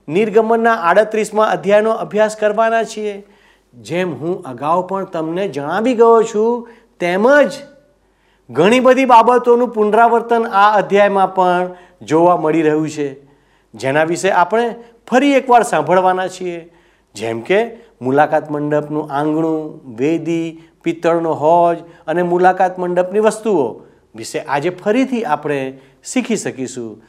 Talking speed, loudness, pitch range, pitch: 115 wpm, -15 LUFS, 160-225 Hz, 185 Hz